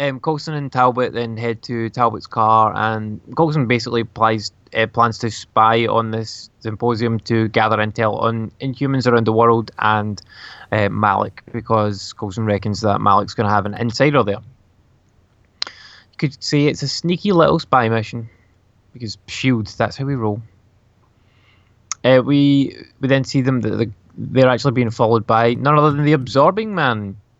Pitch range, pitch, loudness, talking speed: 110-130 Hz, 115 Hz, -18 LUFS, 165 wpm